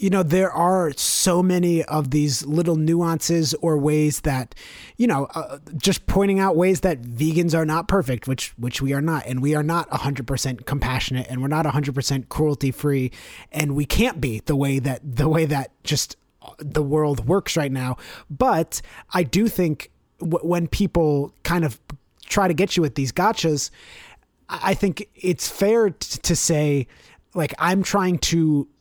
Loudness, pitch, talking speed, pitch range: -22 LUFS, 155 Hz, 185 wpm, 140-175 Hz